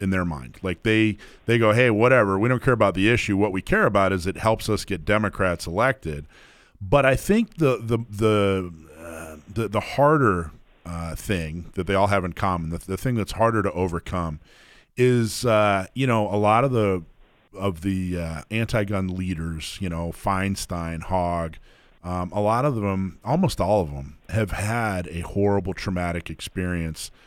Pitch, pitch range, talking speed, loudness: 100 Hz, 85-110 Hz, 185 wpm, -23 LUFS